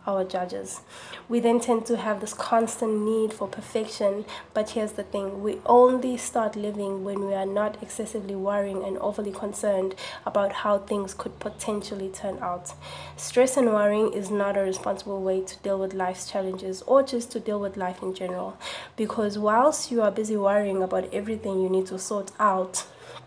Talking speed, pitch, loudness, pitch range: 180 wpm, 205 Hz, -26 LUFS, 195-220 Hz